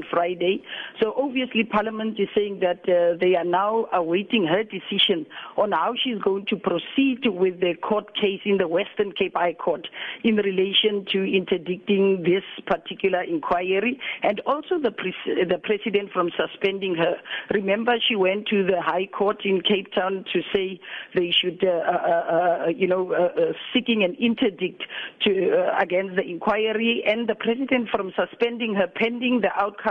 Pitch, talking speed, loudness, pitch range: 200 Hz, 170 wpm, -23 LUFS, 185-225 Hz